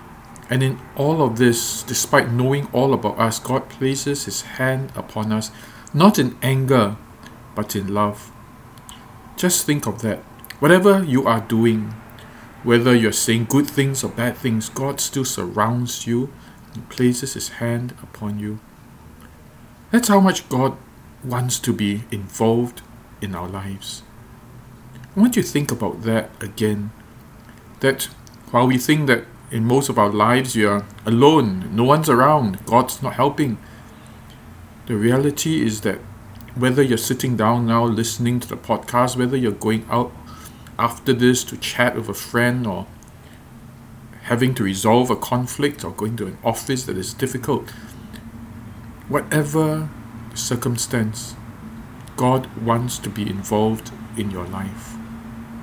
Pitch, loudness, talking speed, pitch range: 120 Hz, -20 LUFS, 145 wpm, 110-130 Hz